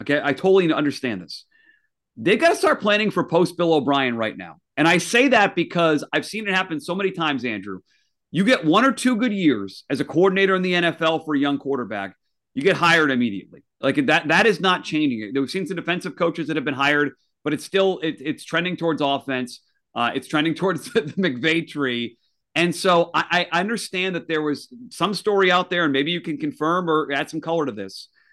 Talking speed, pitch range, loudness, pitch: 215 wpm, 140-185 Hz, -21 LUFS, 165 Hz